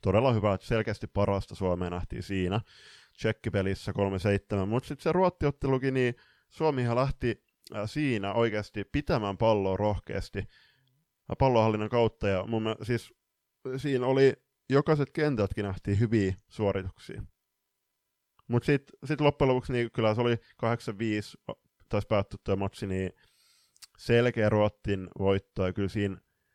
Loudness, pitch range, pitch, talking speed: -29 LUFS, 100-130 Hz, 110 Hz, 125 wpm